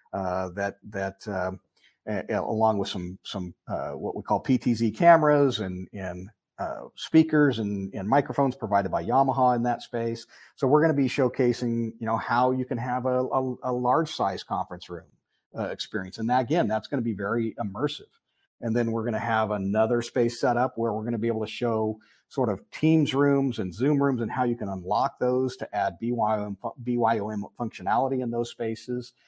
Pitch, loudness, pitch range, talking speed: 115 Hz, -26 LUFS, 105-130 Hz, 195 wpm